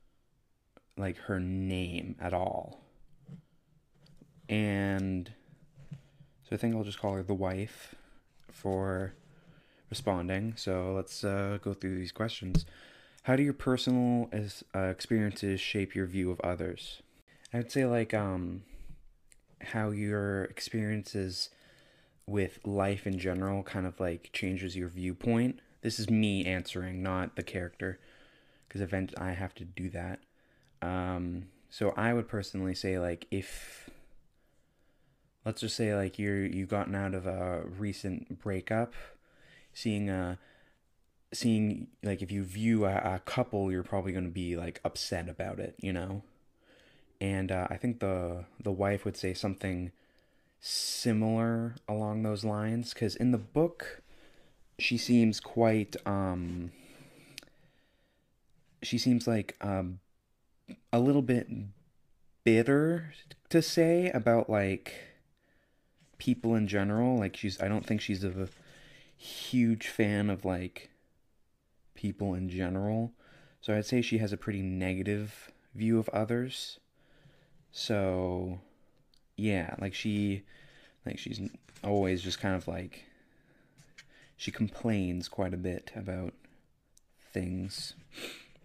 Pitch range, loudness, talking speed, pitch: 95-115 Hz, -33 LUFS, 125 wpm, 100 Hz